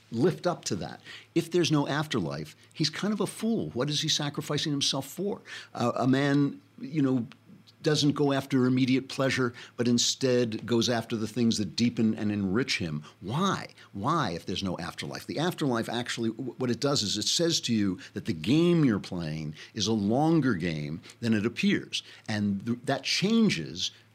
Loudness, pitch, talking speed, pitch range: -28 LUFS, 125 Hz, 185 wpm, 110-150 Hz